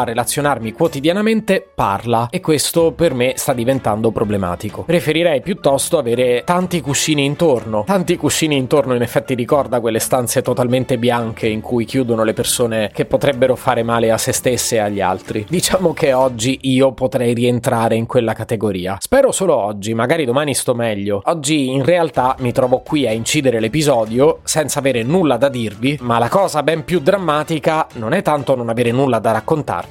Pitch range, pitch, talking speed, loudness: 115-155 Hz, 130 Hz, 175 wpm, -16 LUFS